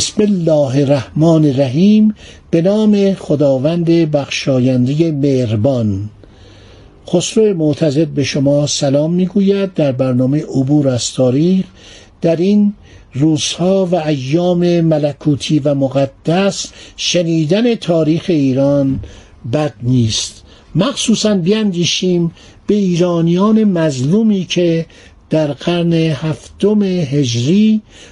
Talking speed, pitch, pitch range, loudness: 90 wpm, 155 Hz, 135-180 Hz, -14 LUFS